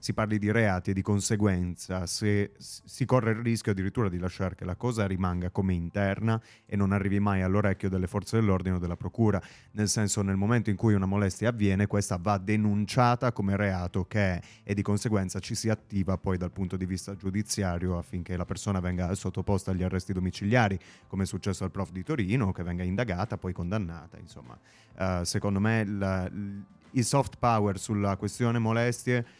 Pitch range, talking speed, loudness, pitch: 95-110 Hz, 190 wpm, -29 LUFS, 100 Hz